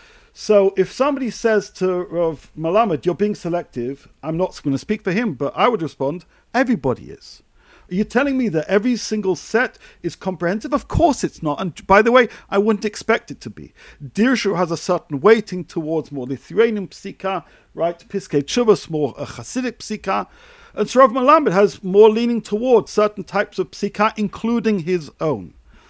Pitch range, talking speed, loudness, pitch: 165-225 Hz, 180 wpm, -19 LUFS, 195 Hz